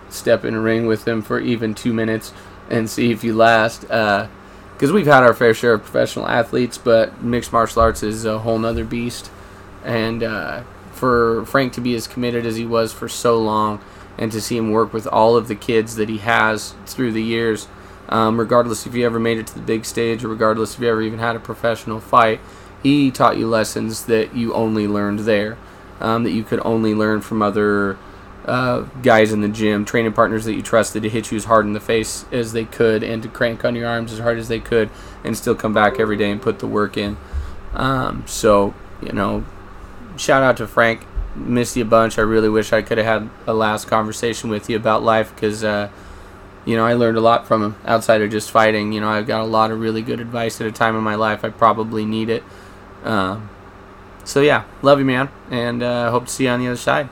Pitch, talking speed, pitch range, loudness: 110 Hz, 230 wpm, 105-115 Hz, -18 LUFS